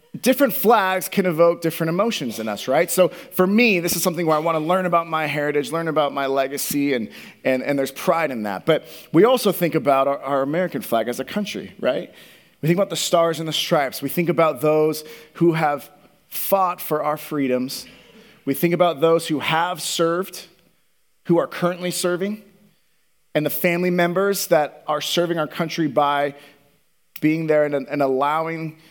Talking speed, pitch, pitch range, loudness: 190 wpm, 165 Hz, 145-180 Hz, -20 LUFS